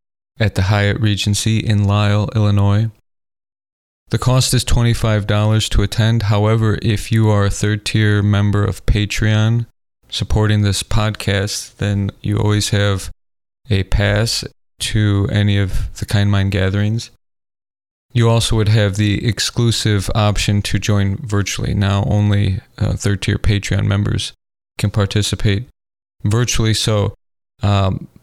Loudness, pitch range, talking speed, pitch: -17 LUFS, 100-110 Hz, 130 wpm, 105 Hz